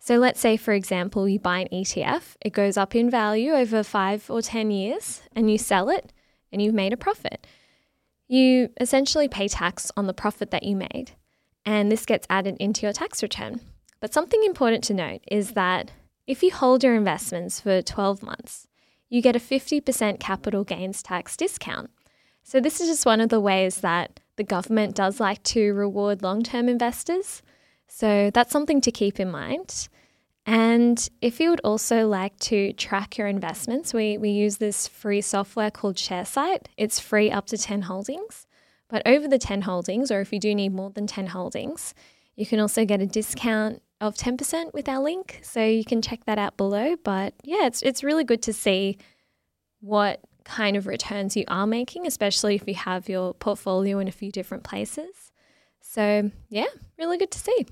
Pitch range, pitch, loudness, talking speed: 200-245 Hz, 215 Hz, -24 LUFS, 190 wpm